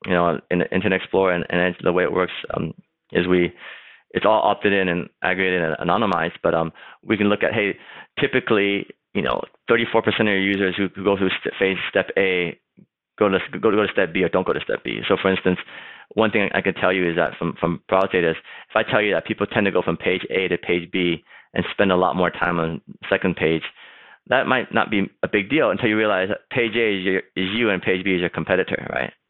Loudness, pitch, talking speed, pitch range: -21 LUFS, 95 Hz, 245 wpm, 90-100 Hz